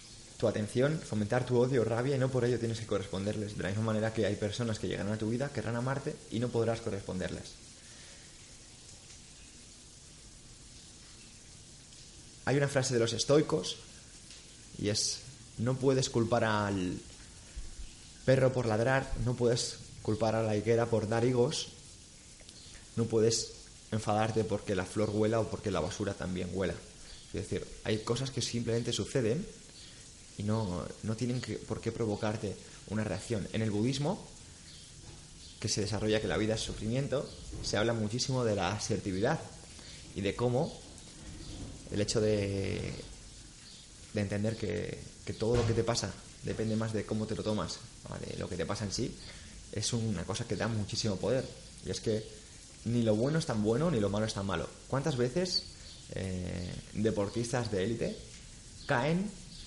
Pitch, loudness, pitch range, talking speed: 110 Hz, -33 LUFS, 100-120 Hz, 160 wpm